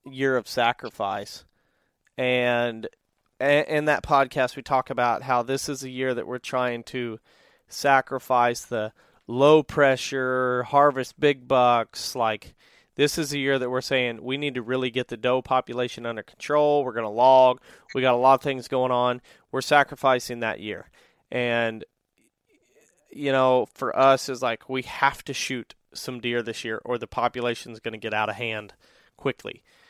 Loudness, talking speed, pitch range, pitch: -24 LUFS, 175 wpm, 120-135 Hz, 130 Hz